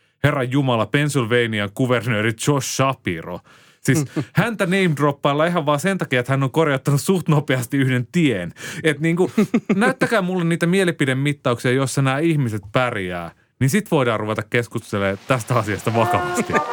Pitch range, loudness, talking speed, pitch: 120-160 Hz, -20 LUFS, 145 wpm, 135 Hz